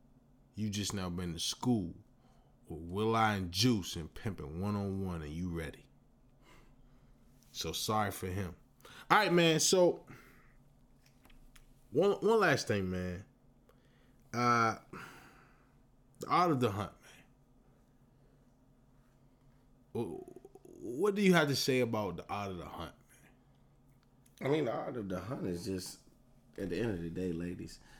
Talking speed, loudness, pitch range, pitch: 145 wpm, -34 LUFS, 95-130 Hz, 125 Hz